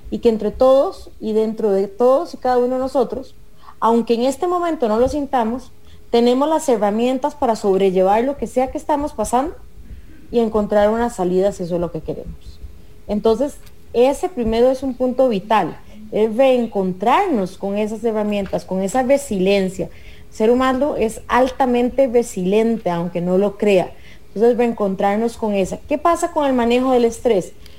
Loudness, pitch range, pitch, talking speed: -18 LUFS, 200-260 Hz, 230 Hz, 165 wpm